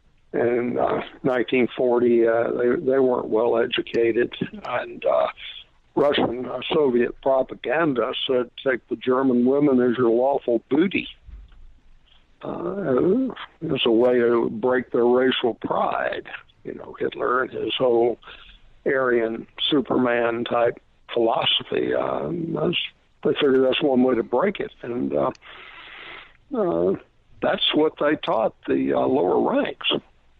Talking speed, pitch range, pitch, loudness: 125 wpm, 115-130 Hz, 120 Hz, -22 LUFS